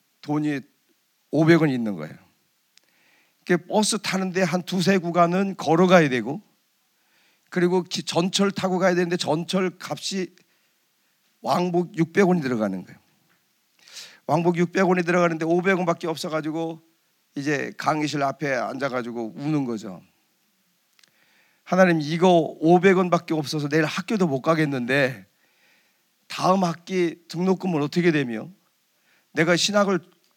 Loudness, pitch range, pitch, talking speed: -22 LUFS, 150-185 Hz, 170 Hz, 255 characters per minute